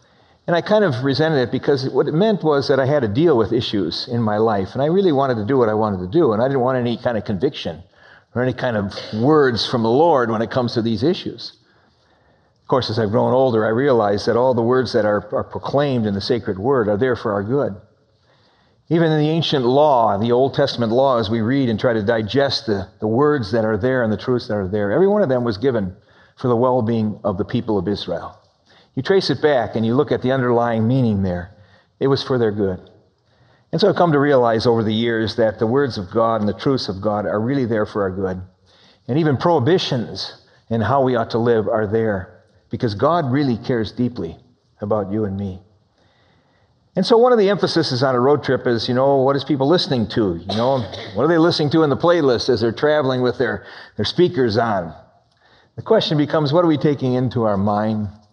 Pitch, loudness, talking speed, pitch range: 120 Hz, -18 LUFS, 235 wpm, 110-140 Hz